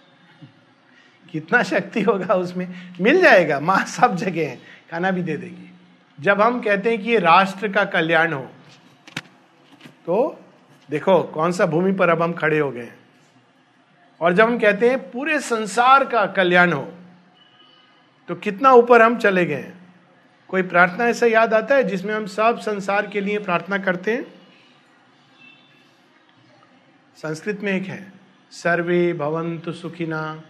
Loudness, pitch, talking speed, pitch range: -19 LUFS, 190 Hz, 140 wpm, 170-220 Hz